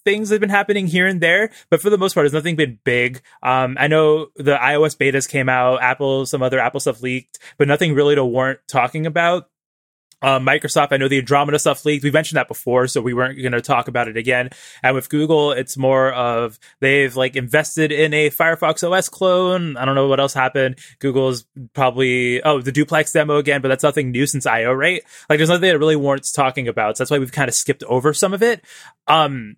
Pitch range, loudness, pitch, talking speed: 130-155 Hz, -17 LUFS, 140 Hz, 230 wpm